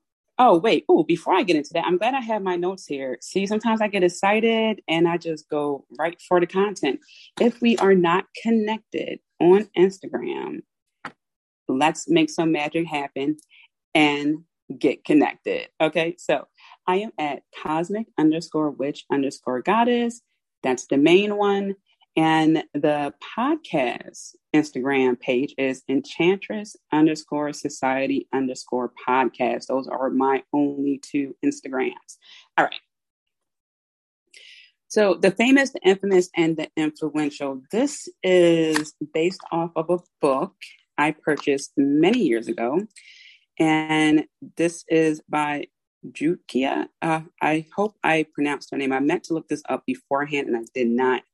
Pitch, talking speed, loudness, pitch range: 165 Hz, 140 wpm, -22 LUFS, 145-220 Hz